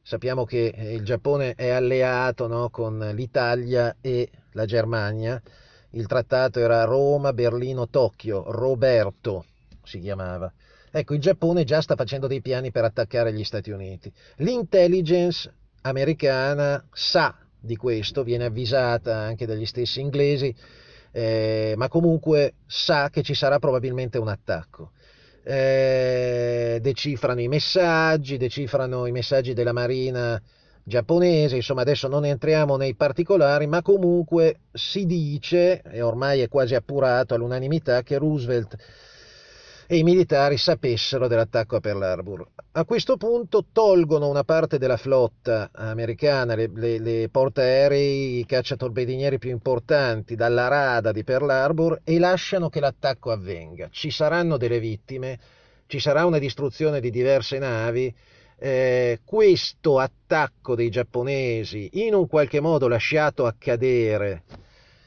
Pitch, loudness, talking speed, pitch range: 130 Hz, -23 LUFS, 130 wpm, 115-145 Hz